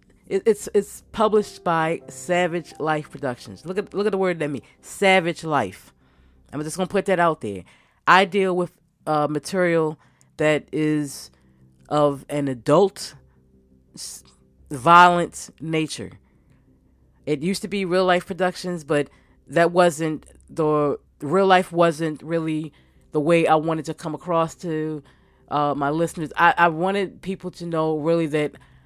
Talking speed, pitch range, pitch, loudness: 145 wpm, 145-180 Hz, 160 Hz, -22 LUFS